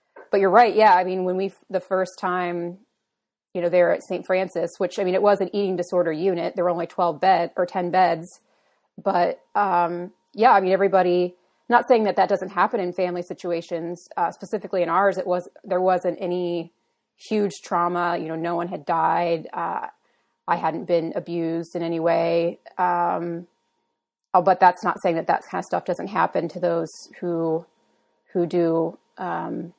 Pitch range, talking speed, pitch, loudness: 170-190 Hz, 185 wpm, 180 Hz, -22 LUFS